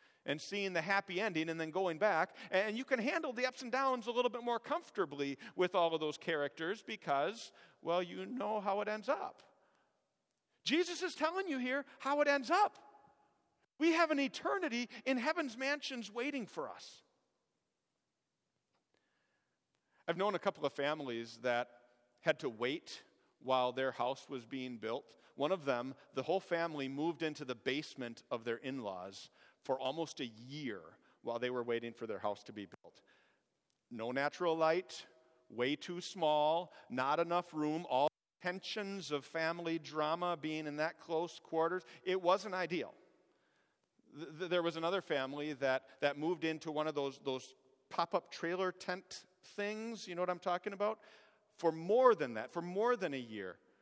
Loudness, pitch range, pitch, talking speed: -38 LUFS, 140-210 Hz, 170 Hz, 170 wpm